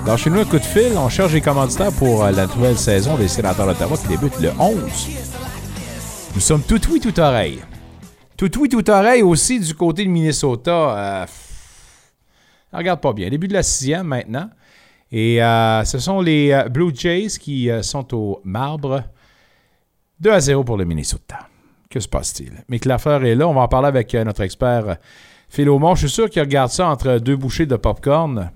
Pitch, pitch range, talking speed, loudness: 135 Hz, 110-165 Hz, 195 wpm, -17 LUFS